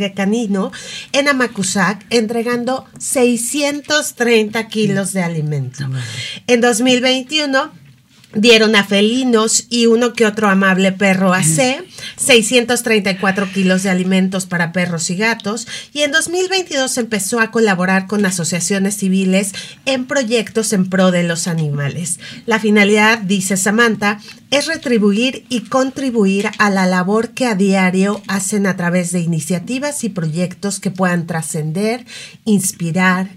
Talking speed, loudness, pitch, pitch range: 130 wpm, -15 LUFS, 205 Hz, 185-240 Hz